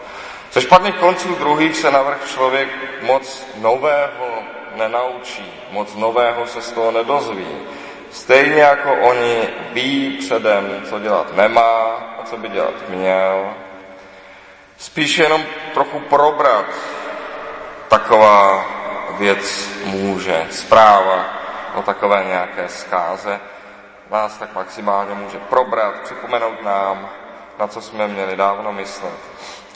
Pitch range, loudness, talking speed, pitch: 100-135 Hz, -16 LUFS, 110 wpm, 115 Hz